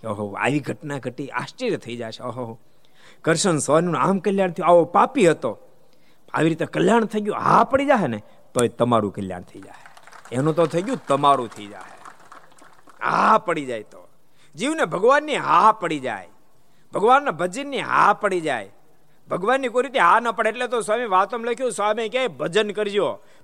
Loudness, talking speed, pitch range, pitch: -21 LUFS, 170 wpm, 140-225 Hz, 175 Hz